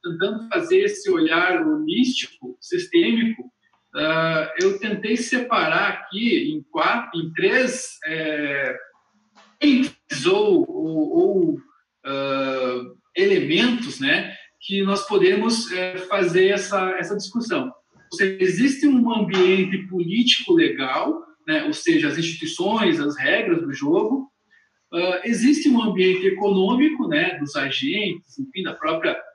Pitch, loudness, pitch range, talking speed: 230 Hz, -21 LUFS, 185-310 Hz, 110 wpm